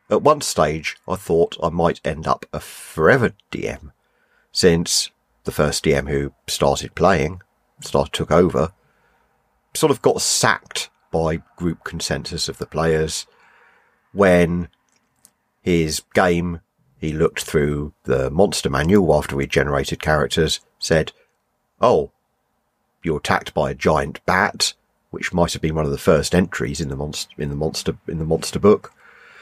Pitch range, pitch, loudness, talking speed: 75-85 Hz, 80 Hz, -20 LUFS, 145 wpm